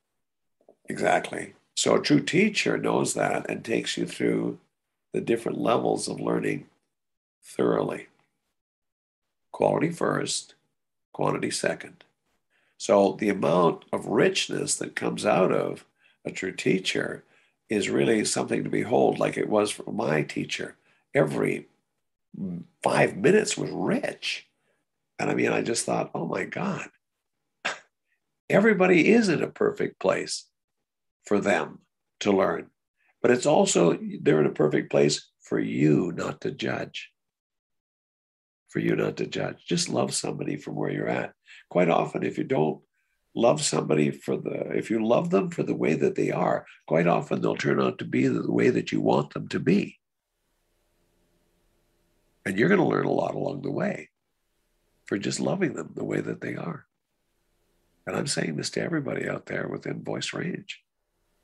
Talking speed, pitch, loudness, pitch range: 155 wpm, 85 Hz, -26 LUFS, 85-105 Hz